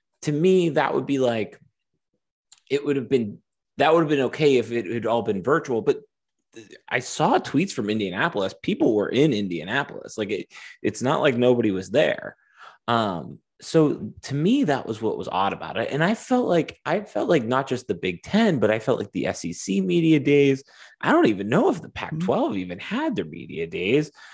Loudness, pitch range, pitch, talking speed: -23 LUFS, 115-165 Hz, 140 Hz, 205 wpm